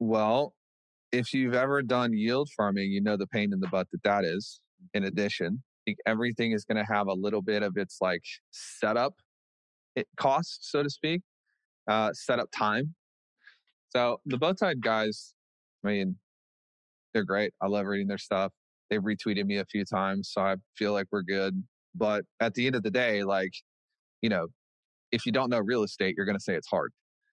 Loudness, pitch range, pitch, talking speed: -30 LUFS, 100-120 Hz, 105 Hz, 195 wpm